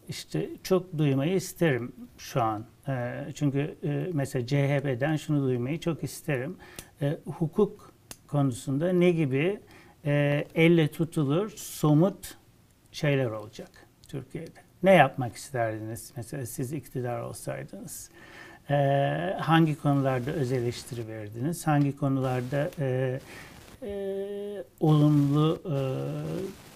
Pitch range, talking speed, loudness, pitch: 130-165 Hz, 105 wpm, -28 LUFS, 145 Hz